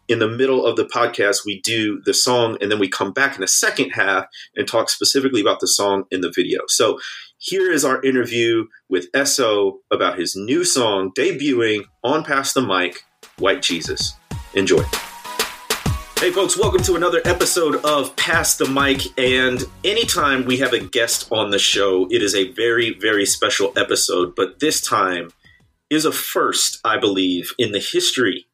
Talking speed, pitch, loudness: 175 wpm, 135 Hz, -18 LUFS